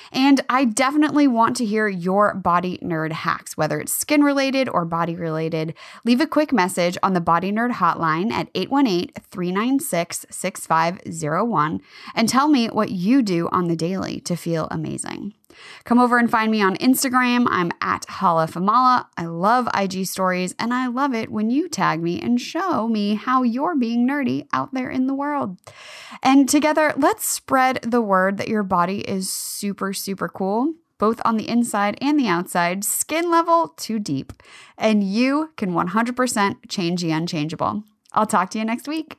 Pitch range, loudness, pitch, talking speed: 180-260 Hz, -20 LUFS, 220 Hz, 175 wpm